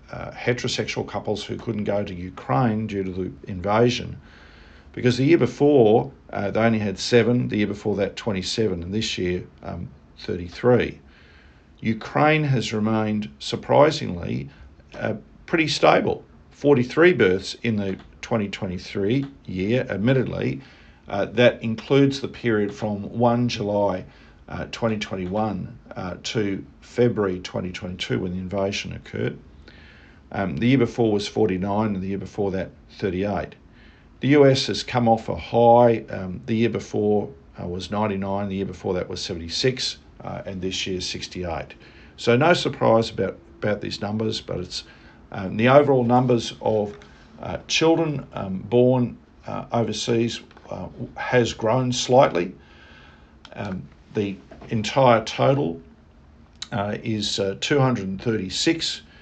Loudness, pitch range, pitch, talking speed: -23 LUFS, 95-120 Hz, 105 Hz, 135 wpm